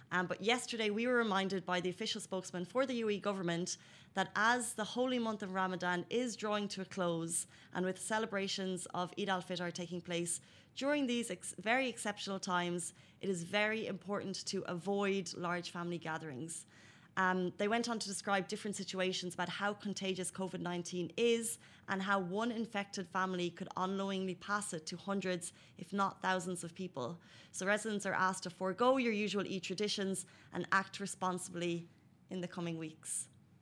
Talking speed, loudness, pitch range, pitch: 175 wpm, -38 LUFS, 180-205 Hz, 190 Hz